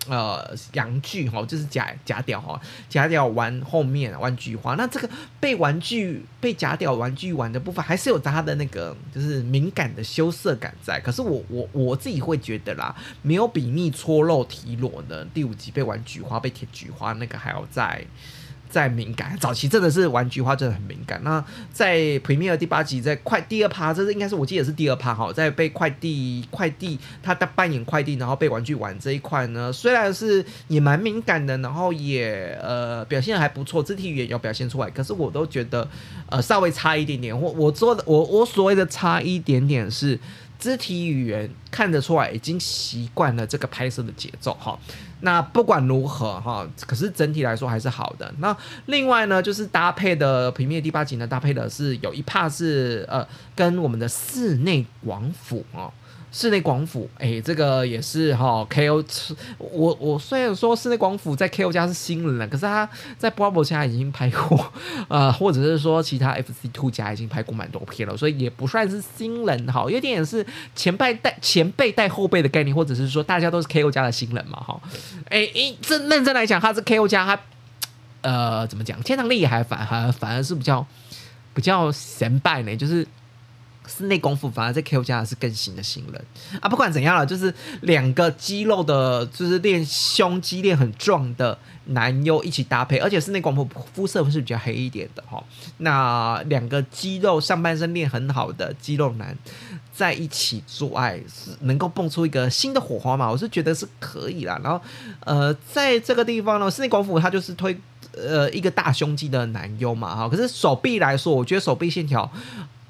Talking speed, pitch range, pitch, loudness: 295 characters per minute, 125-175 Hz, 145 Hz, -22 LUFS